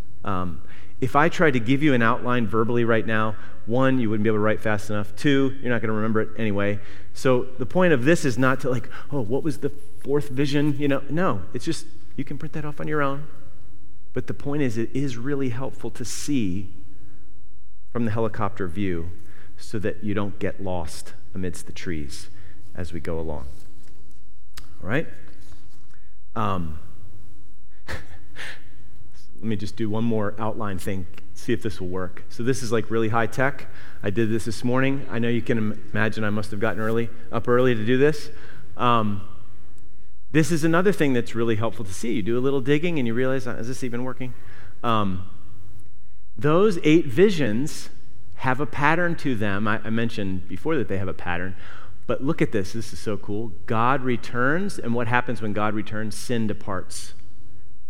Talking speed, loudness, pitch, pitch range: 190 wpm, -25 LUFS, 110 Hz, 100-130 Hz